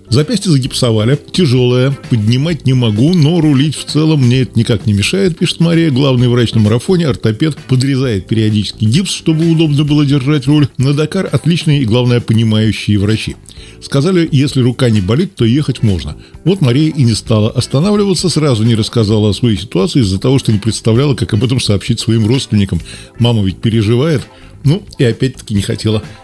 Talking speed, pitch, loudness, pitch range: 175 wpm, 125 Hz, -12 LUFS, 110-150 Hz